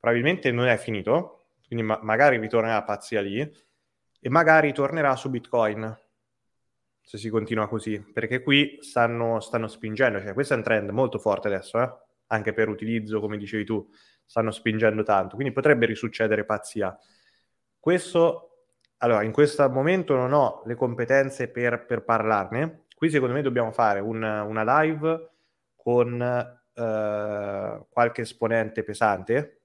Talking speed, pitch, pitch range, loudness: 145 wpm, 120 Hz, 110-135 Hz, -24 LUFS